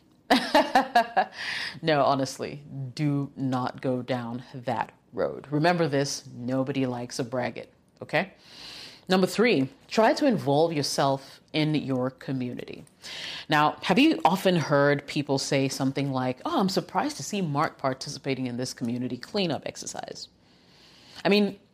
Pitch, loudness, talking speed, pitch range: 140 Hz, -26 LUFS, 130 wpm, 130-180 Hz